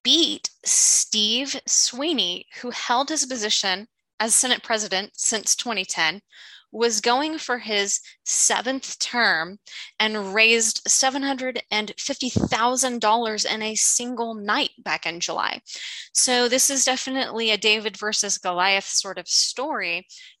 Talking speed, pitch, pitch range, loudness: 115 wpm, 225 Hz, 210-255 Hz, -21 LUFS